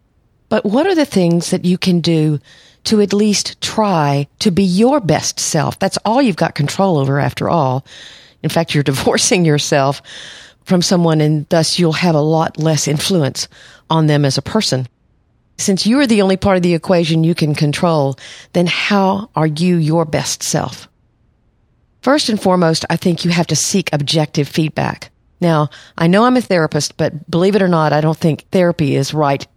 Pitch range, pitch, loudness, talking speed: 150-190 Hz, 165 Hz, -15 LUFS, 190 wpm